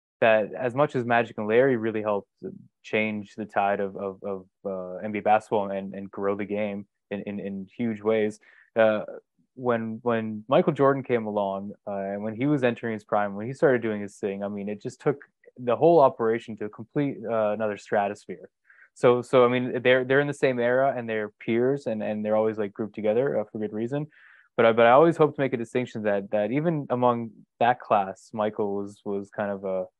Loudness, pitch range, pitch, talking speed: -25 LUFS, 100-125 Hz, 110 Hz, 215 wpm